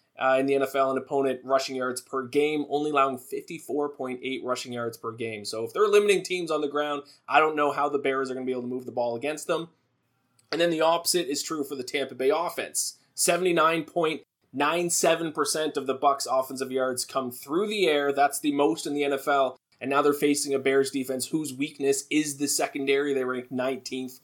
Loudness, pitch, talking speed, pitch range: -26 LUFS, 140 Hz, 225 wpm, 130-150 Hz